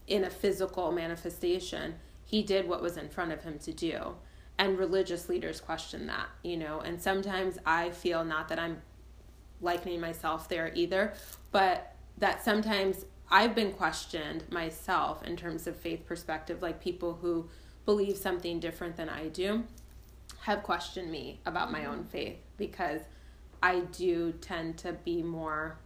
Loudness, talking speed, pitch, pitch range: -33 LUFS, 155 wpm, 175 Hz, 165-190 Hz